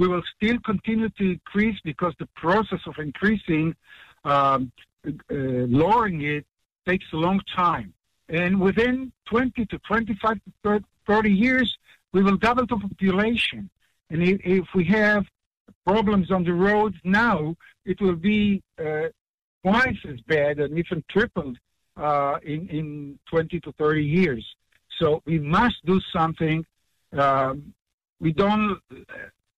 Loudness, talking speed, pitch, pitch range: -23 LUFS, 135 wpm, 185 Hz, 155-210 Hz